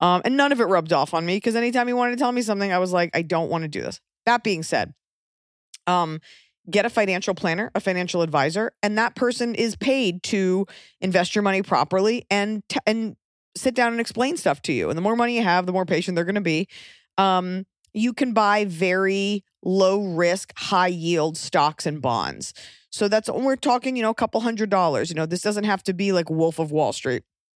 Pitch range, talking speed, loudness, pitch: 175-225 Hz, 230 wpm, -22 LUFS, 195 Hz